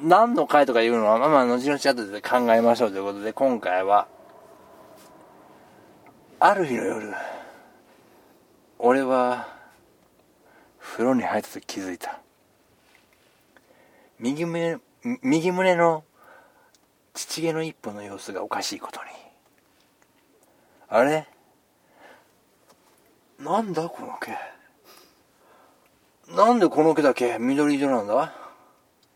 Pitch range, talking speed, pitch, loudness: 120-180 Hz, 195 characters per minute, 145 Hz, -23 LUFS